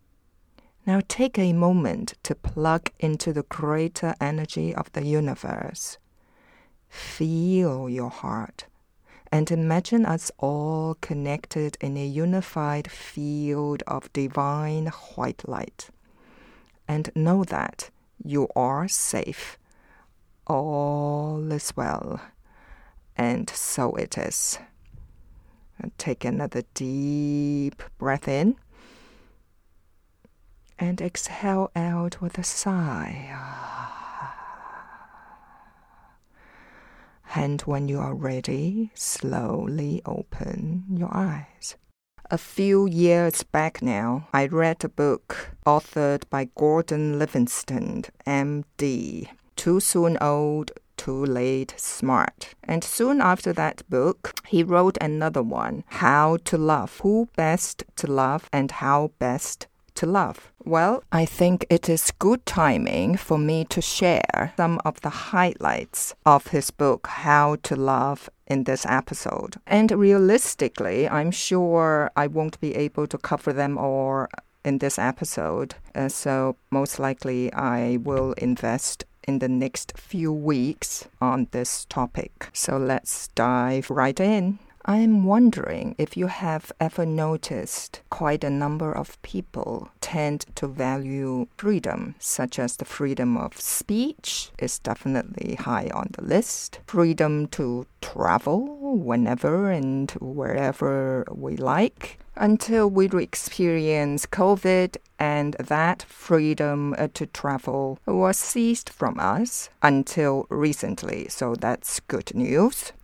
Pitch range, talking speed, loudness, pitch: 140-180 Hz, 115 wpm, -24 LUFS, 155 Hz